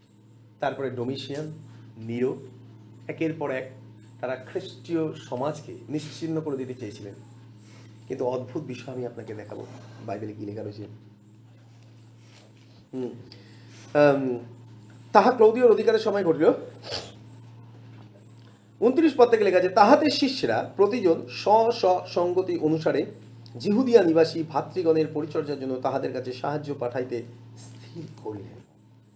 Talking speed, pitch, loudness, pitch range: 95 wpm, 125 Hz, -25 LUFS, 115-155 Hz